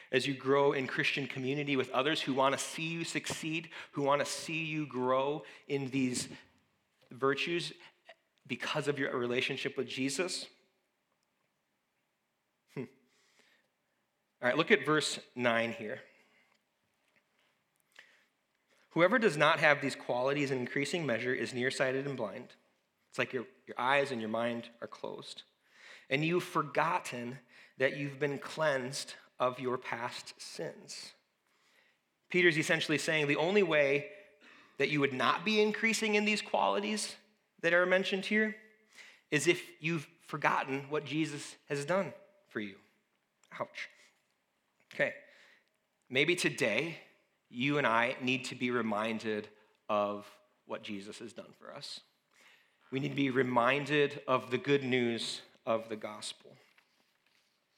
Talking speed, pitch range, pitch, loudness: 135 wpm, 130-165 Hz, 140 Hz, -32 LUFS